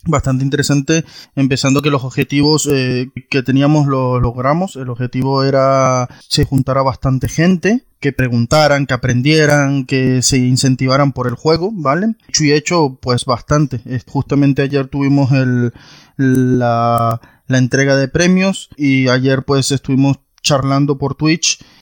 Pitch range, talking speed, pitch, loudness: 130-145 Hz, 140 wpm, 135 Hz, -14 LUFS